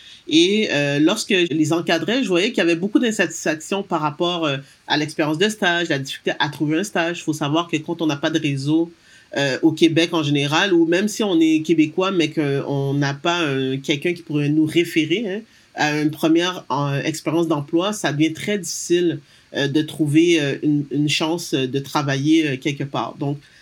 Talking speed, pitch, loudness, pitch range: 205 wpm, 160 Hz, -20 LUFS, 150-175 Hz